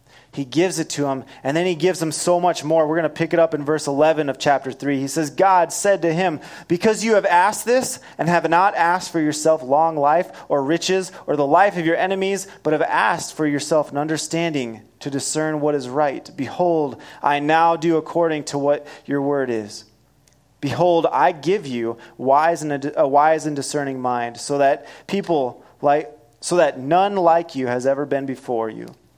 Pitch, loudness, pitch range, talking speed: 155 Hz, -20 LUFS, 140-170 Hz, 200 wpm